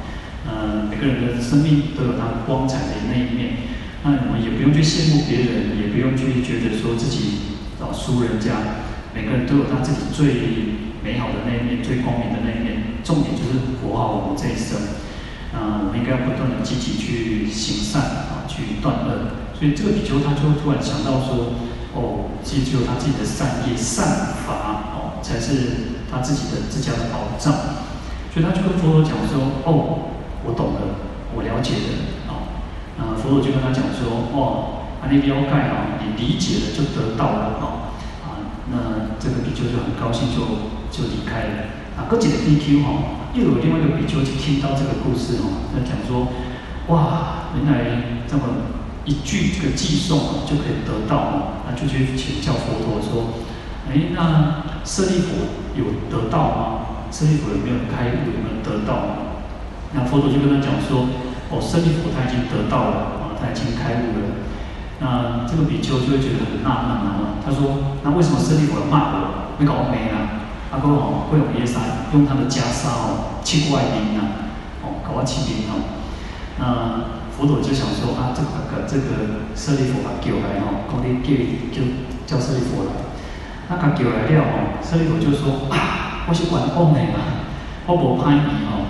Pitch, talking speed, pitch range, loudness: 125 Hz, 265 characters per minute, 115-145 Hz, -21 LUFS